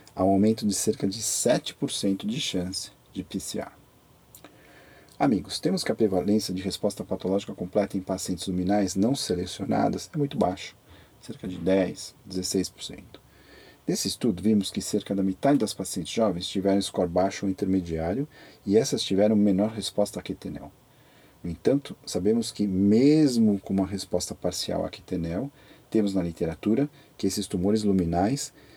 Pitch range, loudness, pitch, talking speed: 95-110 Hz, -26 LUFS, 100 Hz, 150 wpm